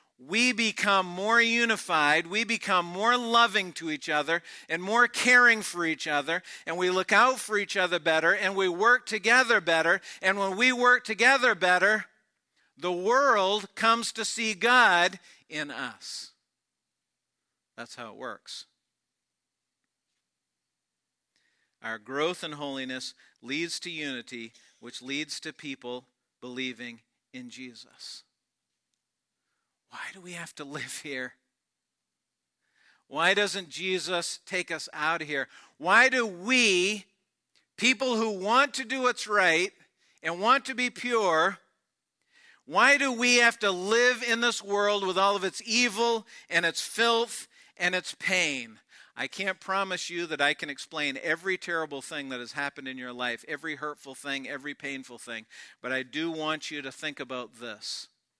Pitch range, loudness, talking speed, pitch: 145-225 Hz, -26 LUFS, 150 wpm, 180 Hz